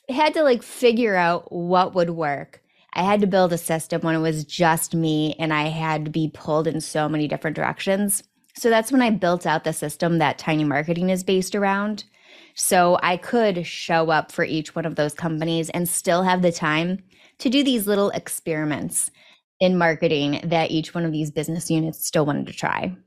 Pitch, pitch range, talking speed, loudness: 170 Hz, 155-190 Hz, 205 wpm, -22 LUFS